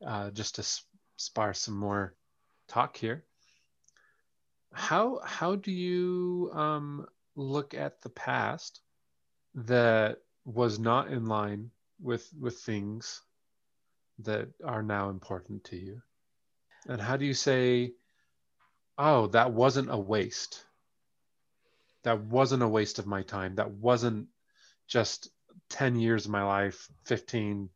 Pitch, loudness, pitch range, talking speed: 115 Hz, -31 LUFS, 100-130 Hz, 125 wpm